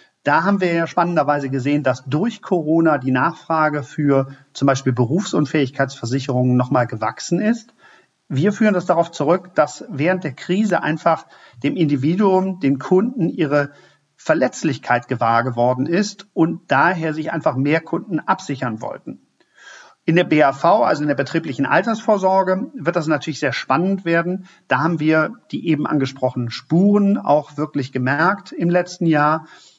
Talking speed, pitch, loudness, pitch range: 145 wpm, 155 Hz, -19 LUFS, 140-180 Hz